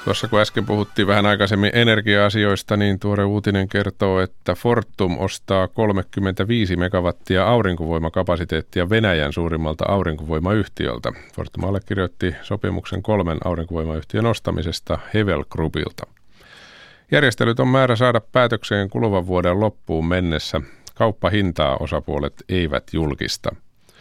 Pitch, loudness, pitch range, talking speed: 95 Hz, -20 LUFS, 85-105 Hz, 100 wpm